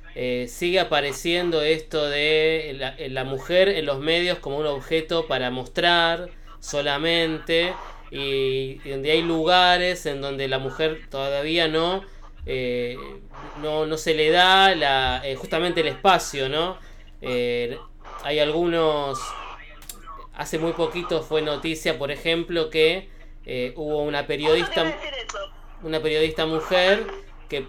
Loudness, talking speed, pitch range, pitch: -22 LUFS, 125 wpm, 140-165 Hz, 155 Hz